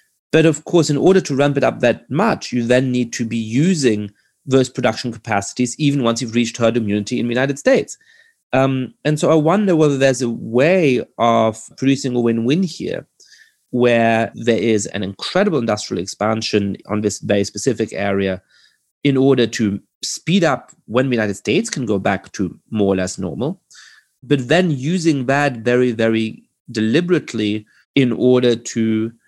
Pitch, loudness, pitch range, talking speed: 120 Hz, -18 LUFS, 110-140 Hz, 170 wpm